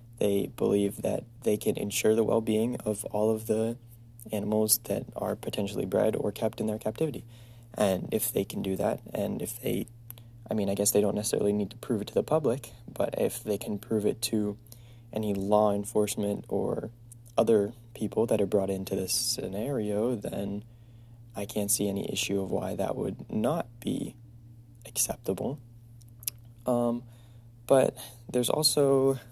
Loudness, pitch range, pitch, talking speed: -29 LUFS, 105-115 Hz, 115 Hz, 165 wpm